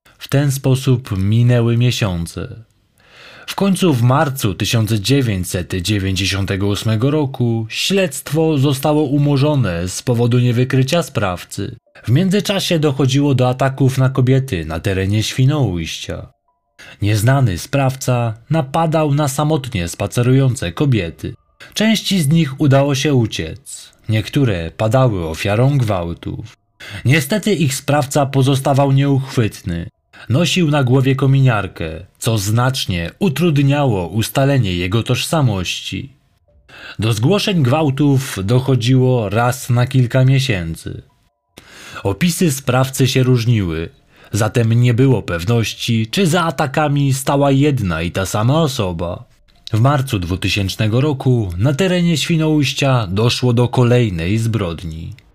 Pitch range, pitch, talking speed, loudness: 105-140 Hz, 125 Hz, 105 wpm, -16 LUFS